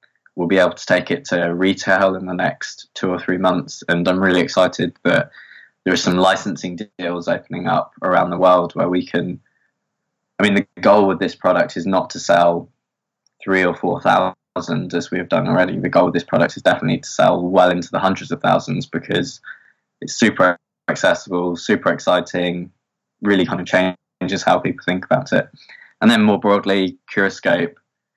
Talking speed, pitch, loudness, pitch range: 185 wpm, 90 Hz, -18 LUFS, 90-95 Hz